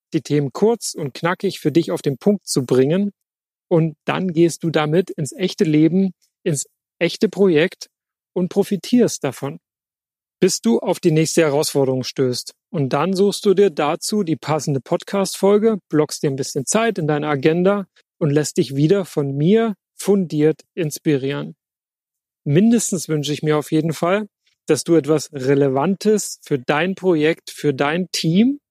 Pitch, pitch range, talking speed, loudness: 165 Hz, 150-190 Hz, 155 wpm, -19 LUFS